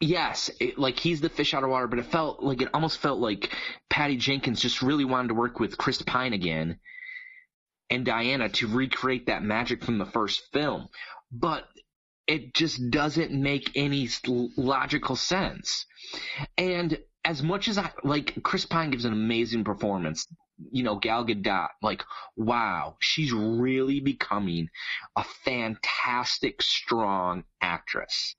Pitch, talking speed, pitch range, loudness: 130 Hz, 150 wpm, 115-150 Hz, -27 LUFS